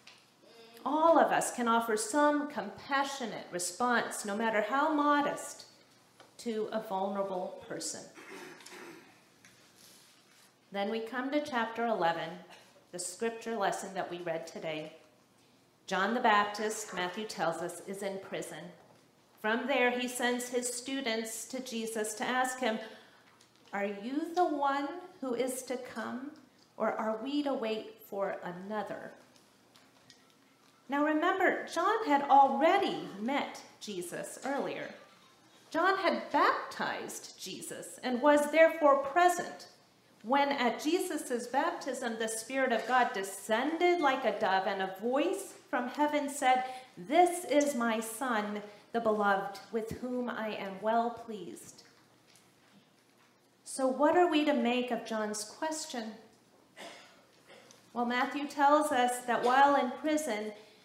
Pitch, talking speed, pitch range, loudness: 245 Hz, 125 wpm, 215-280 Hz, -32 LUFS